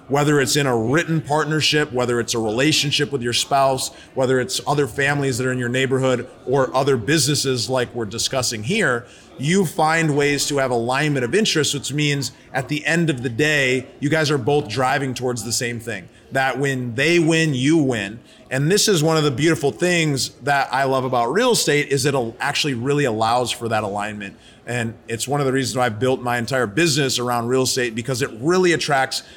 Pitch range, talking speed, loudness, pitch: 125-150 Hz, 205 wpm, -19 LUFS, 135 Hz